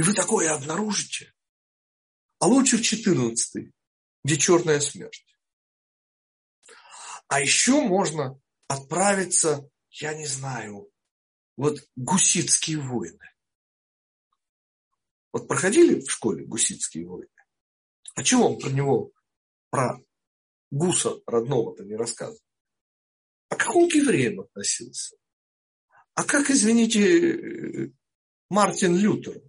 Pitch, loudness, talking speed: 180 Hz, -23 LUFS, 100 wpm